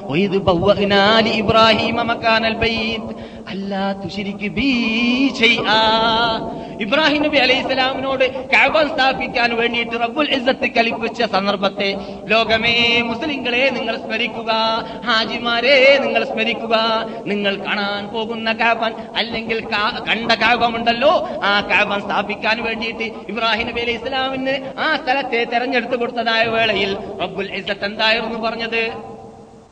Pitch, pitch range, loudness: 225 Hz, 205-240 Hz, -17 LUFS